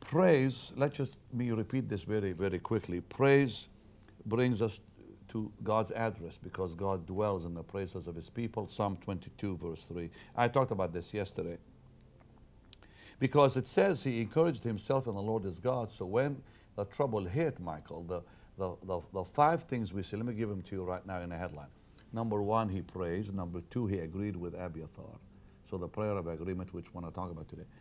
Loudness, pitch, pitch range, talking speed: -35 LUFS, 105 Hz, 90-115 Hz, 195 wpm